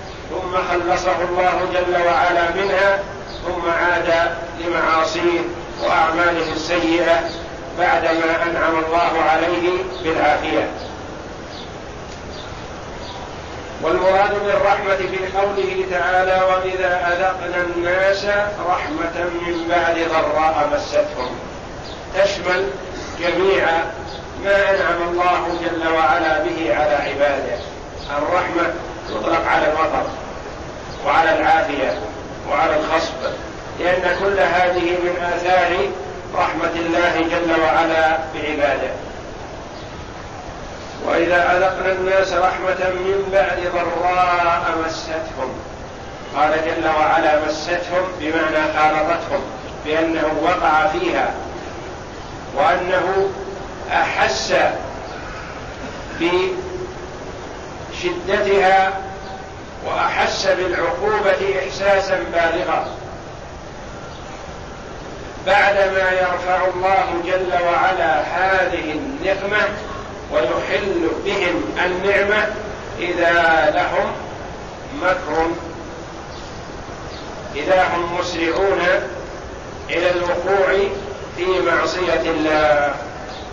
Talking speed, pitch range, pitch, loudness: 75 wpm, 165-185 Hz, 175 Hz, -18 LUFS